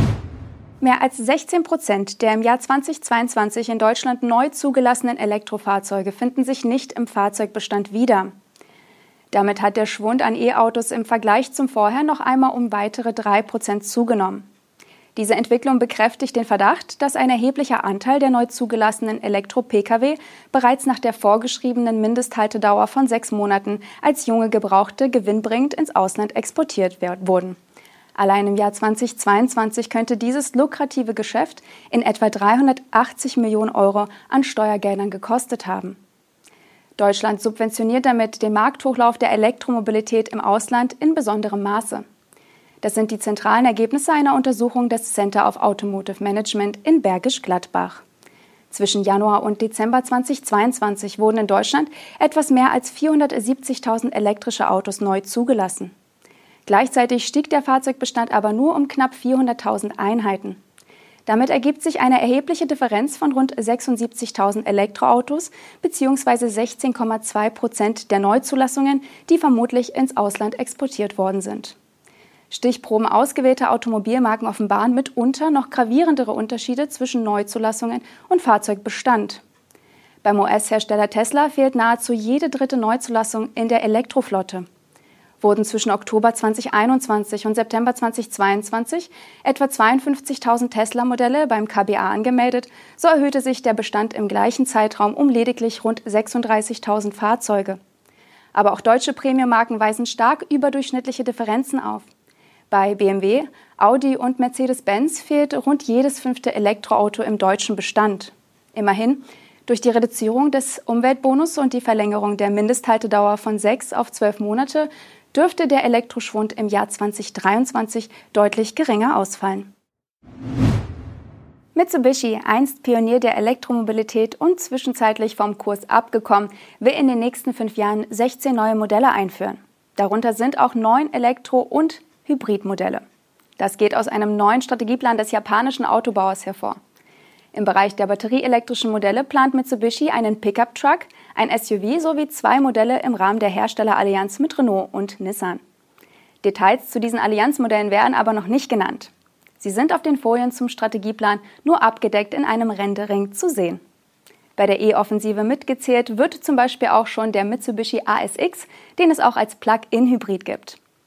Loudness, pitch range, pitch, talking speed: -19 LUFS, 210-260 Hz, 230 Hz, 130 wpm